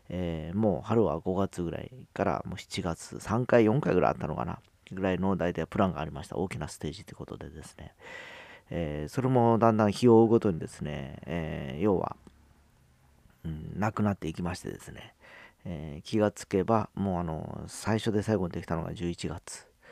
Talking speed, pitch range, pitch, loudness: 360 characters per minute, 85-110 Hz, 95 Hz, -29 LUFS